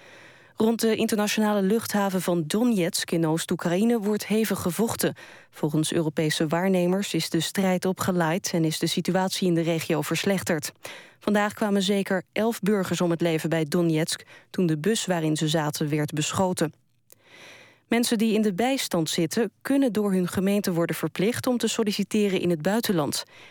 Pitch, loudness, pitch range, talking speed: 185 Hz, -25 LUFS, 165-210 Hz, 160 wpm